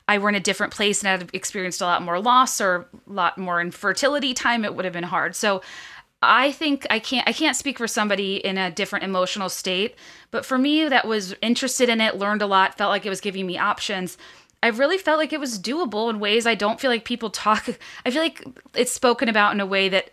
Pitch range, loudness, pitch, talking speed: 190-245 Hz, -22 LUFS, 210 Hz, 245 wpm